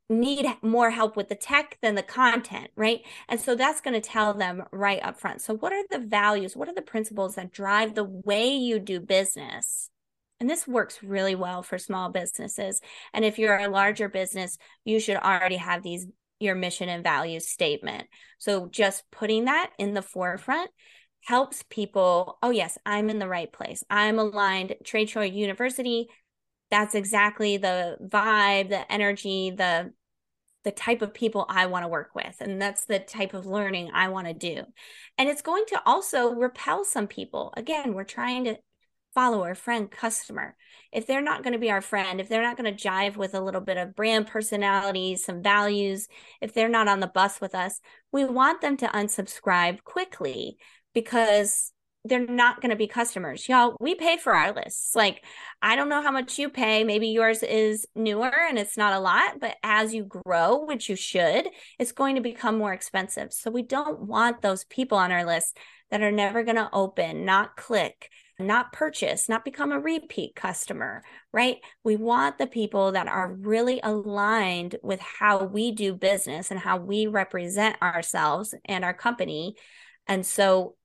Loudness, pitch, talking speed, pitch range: -26 LUFS, 210 Hz, 185 wpm, 195-235 Hz